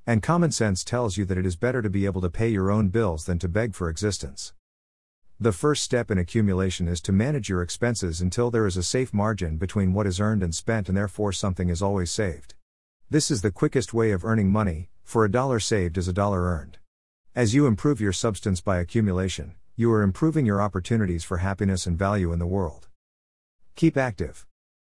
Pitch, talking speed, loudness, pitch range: 100 Hz, 210 wpm, -25 LUFS, 90-115 Hz